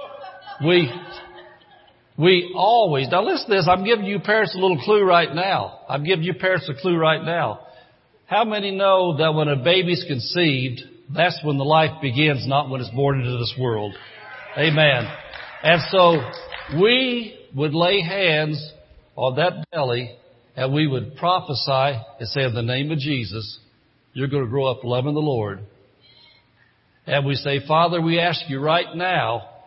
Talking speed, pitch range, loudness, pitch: 165 wpm, 130-175 Hz, -20 LUFS, 150 Hz